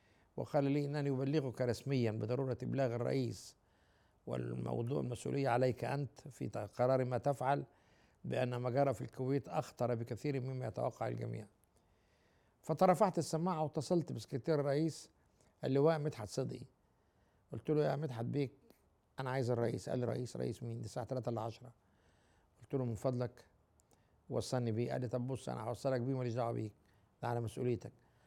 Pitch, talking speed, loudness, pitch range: 125 Hz, 150 wpm, -38 LUFS, 115-140 Hz